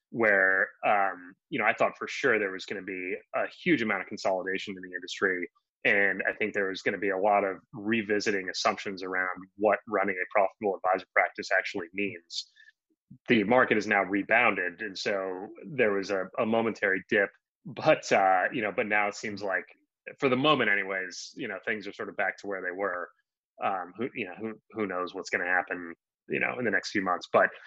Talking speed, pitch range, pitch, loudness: 215 wpm, 95-110 Hz, 100 Hz, -28 LUFS